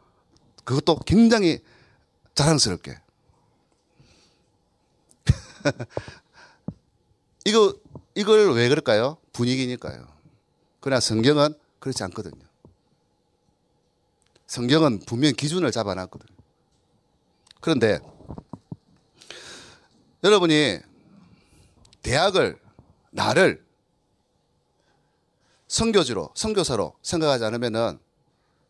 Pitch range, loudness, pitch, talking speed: 115-160 Hz, -22 LUFS, 140 Hz, 170 characters per minute